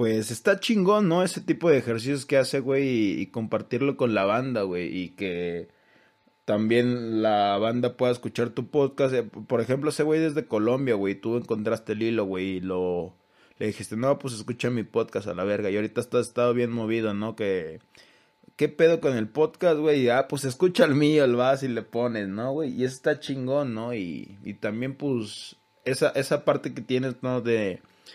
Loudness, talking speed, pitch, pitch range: -25 LUFS, 195 wpm, 120 Hz, 110-135 Hz